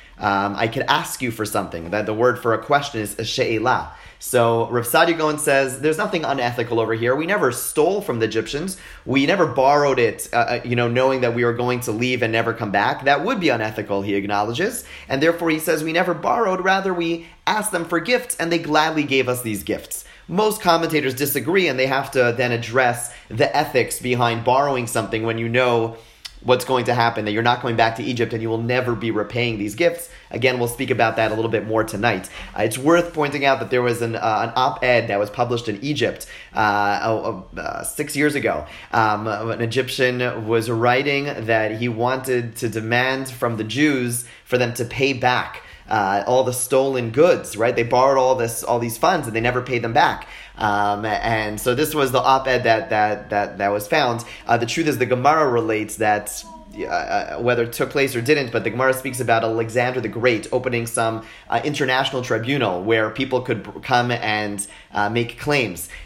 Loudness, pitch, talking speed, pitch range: -20 LUFS, 120 Hz, 210 wpm, 115-135 Hz